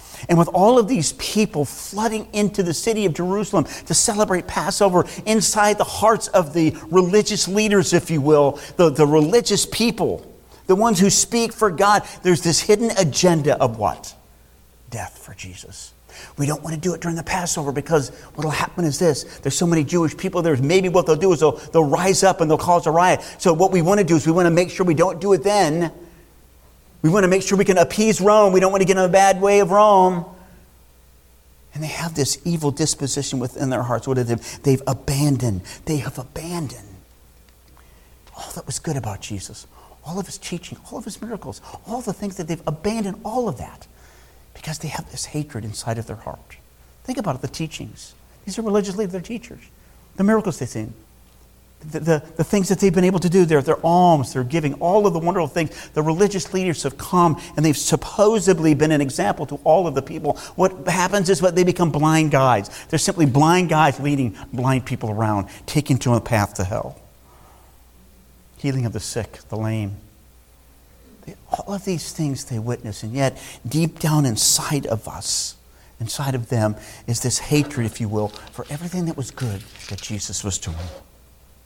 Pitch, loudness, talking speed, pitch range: 155 Hz, -19 LUFS, 200 wpm, 115-185 Hz